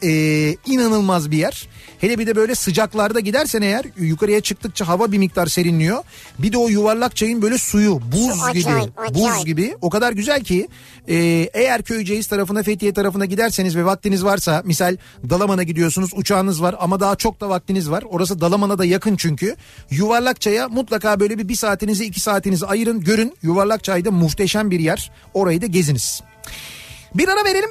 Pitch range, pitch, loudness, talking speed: 175-215 Hz, 200 Hz, -18 LUFS, 170 wpm